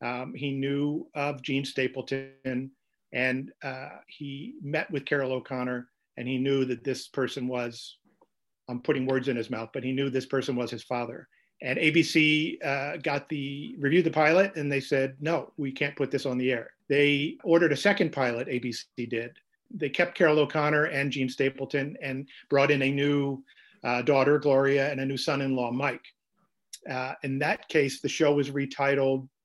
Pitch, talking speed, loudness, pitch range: 140 Hz, 185 wpm, -27 LUFS, 130-145 Hz